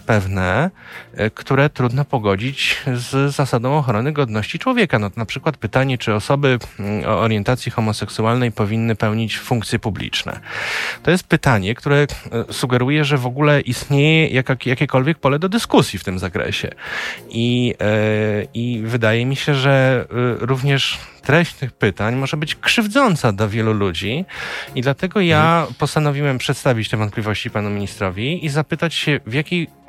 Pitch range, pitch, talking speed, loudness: 110-145 Hz, 125 Hz, 140 wpm, -18 LUFS